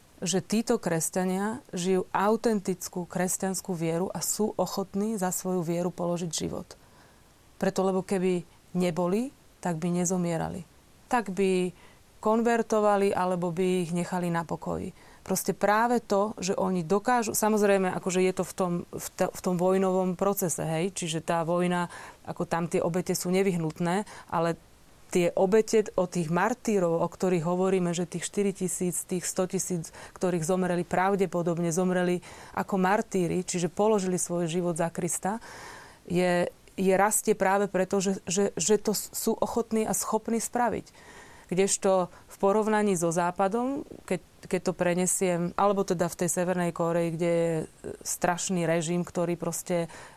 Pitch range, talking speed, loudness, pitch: 175-200 Hz, 145 wpm, -28 LUFS, 185 Hz